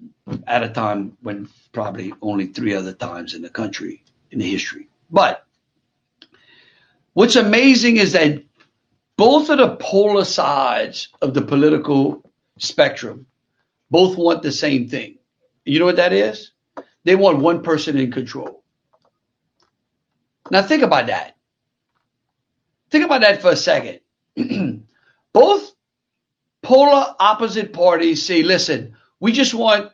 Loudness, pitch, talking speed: -16 LUFS, 175 Hz, 130 wpm